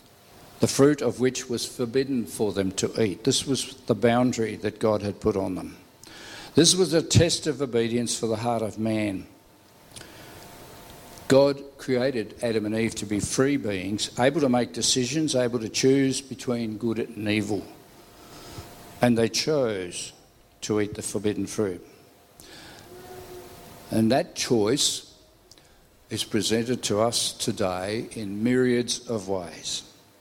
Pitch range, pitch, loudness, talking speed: 105-125 Hz, 115 Hz, -25 LUFS, 140 wpm